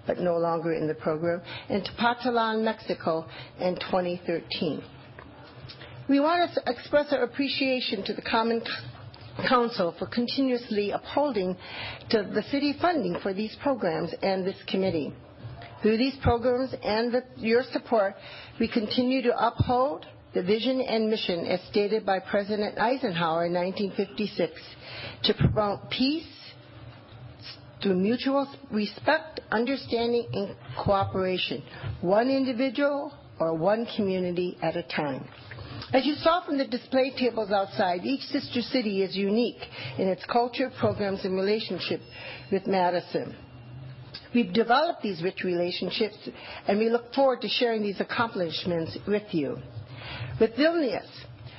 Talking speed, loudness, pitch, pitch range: 130 wpm, -27 LUFS, 205 Hz, 170-245 Hz